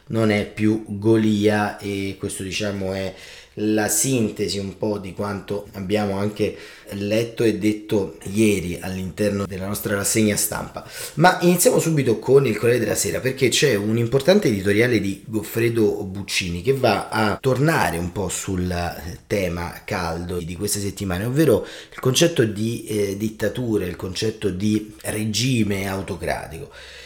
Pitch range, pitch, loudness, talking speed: 95-110 Hz, 105 Hz, -21 LUFS, 140 wpm